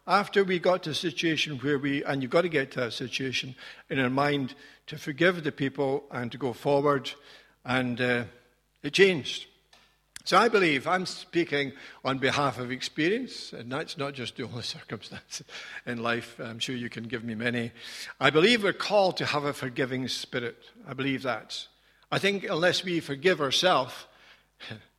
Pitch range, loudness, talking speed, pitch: 125-160 Hz, -27 LUFS, 180 wpm, 140 Hz